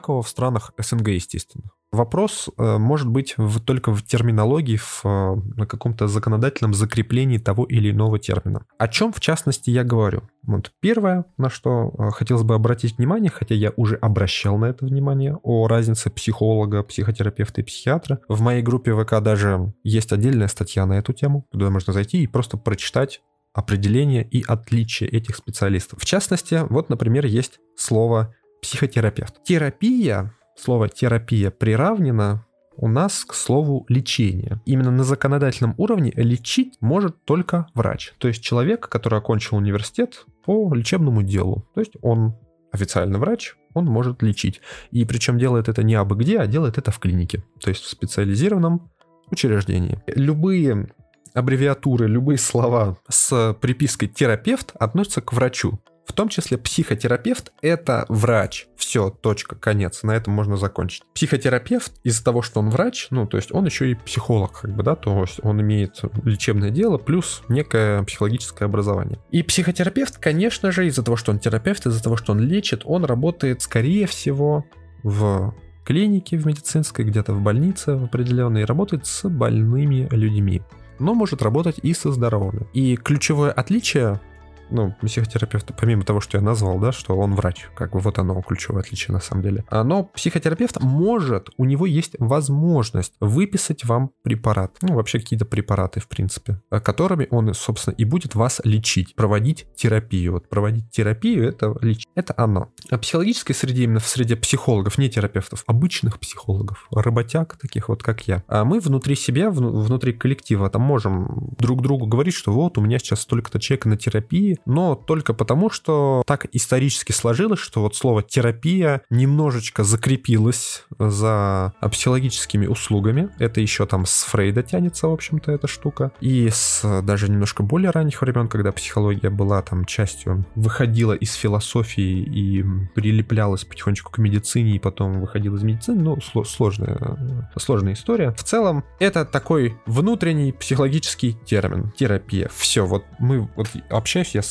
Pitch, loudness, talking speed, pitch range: 115 Hz, -20 LUFS, 155 wpm, 105-140 Hz